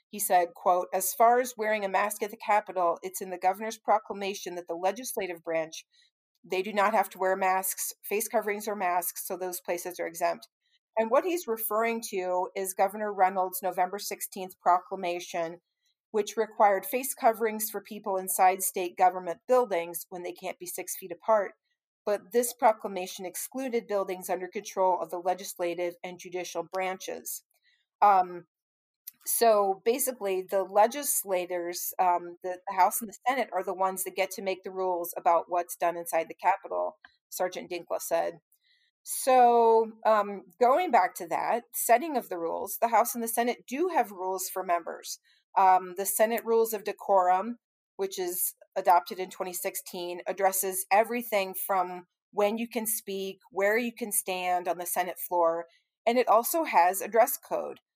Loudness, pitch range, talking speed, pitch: -28 LUFS, 180-225 Hz, 165 wpm, 195 Hz